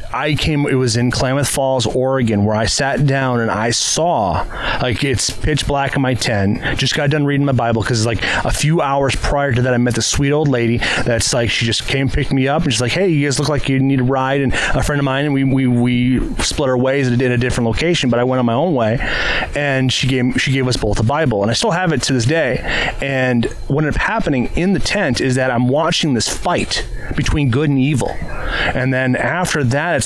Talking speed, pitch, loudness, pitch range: 255 wpm, 130 Hz, -16 LUFS, 120-140 Hz